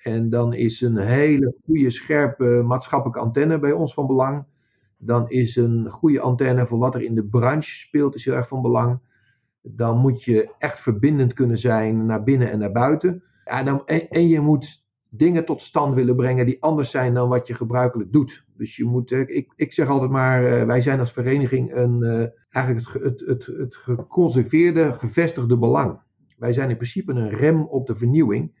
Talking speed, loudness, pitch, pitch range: 185 wpm, -20 LUFS, 125 Hz, 120-140 Hz